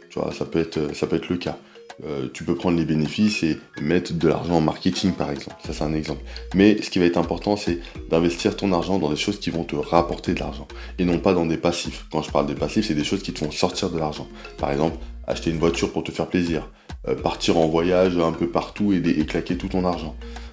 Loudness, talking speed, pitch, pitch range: -23 LUFS, 255 wpm, 85 Hz, 75-90 Hz